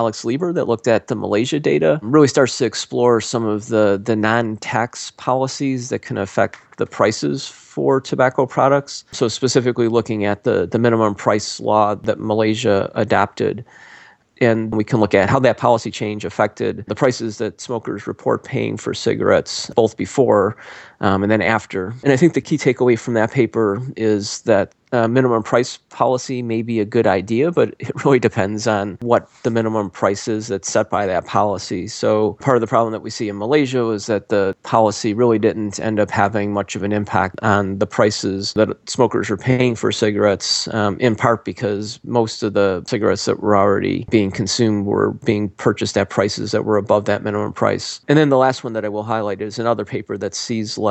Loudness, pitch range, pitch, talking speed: -18 LUFS, 105-120 Hz, 110 Hz, 200 wpm